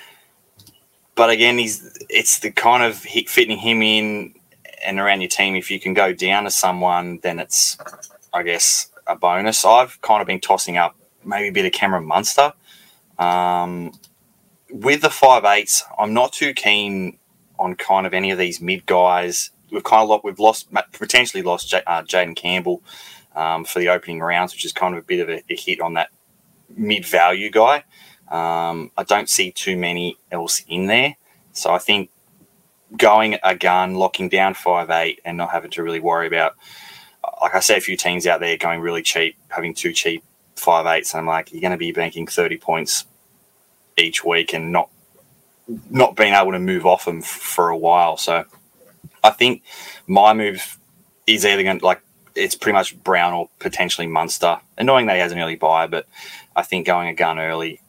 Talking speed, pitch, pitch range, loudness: 190 wpm, 90 Hz, 85-110 Hz, -18 LUFS